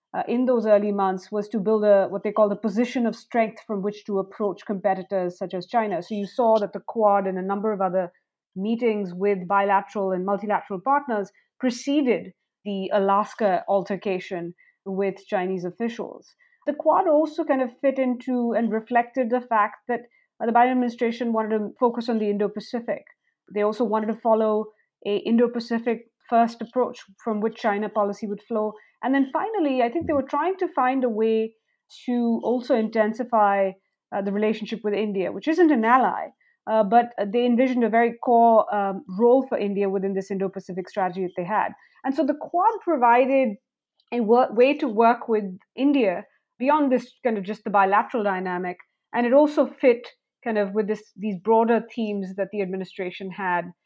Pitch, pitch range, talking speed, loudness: 220 Hz, 200-245 Hz, 185 wpm, -23 LUFS